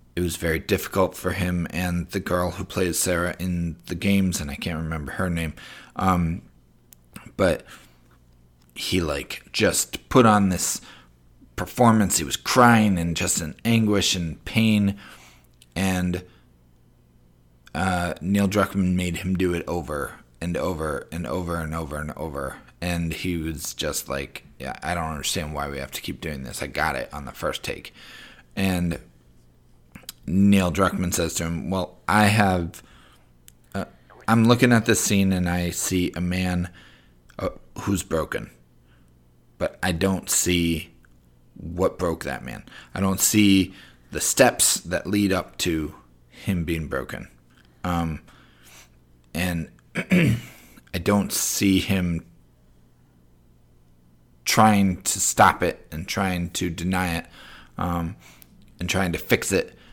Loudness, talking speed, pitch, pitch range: -23 LUFS, 145 wpm, 85 Hz, 60-95 Hz